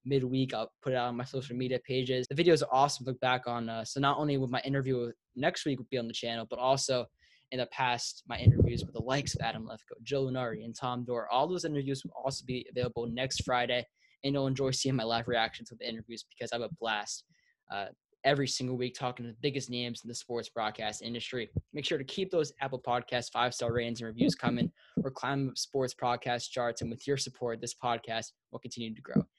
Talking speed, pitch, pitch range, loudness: 240 wpm, 125 Hz, 115-135 Hz, -33 LUFS